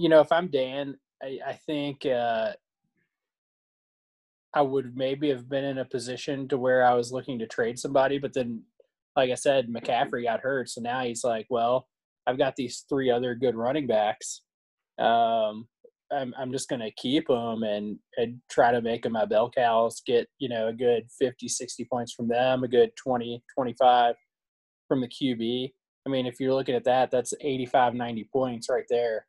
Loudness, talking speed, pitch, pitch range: -27 LUFS, 190 wpm, 125 Hz, 120-135 Hz